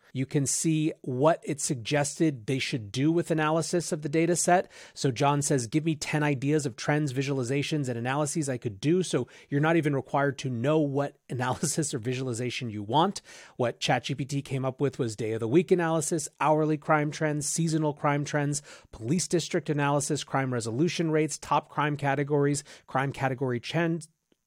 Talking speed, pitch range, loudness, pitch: 175 wpm, 135-160 Hz, -28 LUFS, 145 Hz